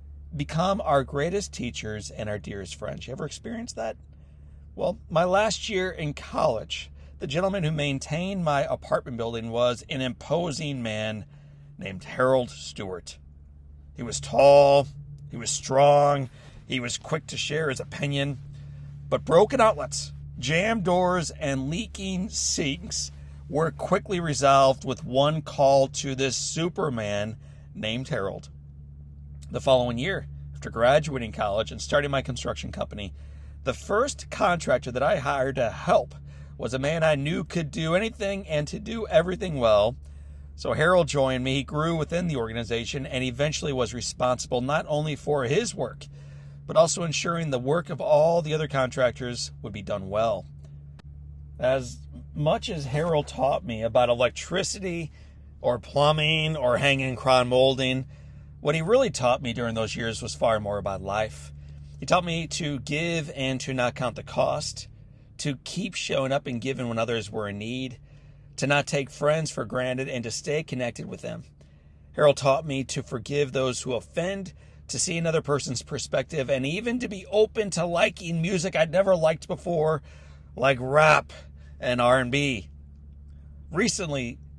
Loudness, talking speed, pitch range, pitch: -26 LUFS, 155 wpm, 105-155 Hz, 135 Hz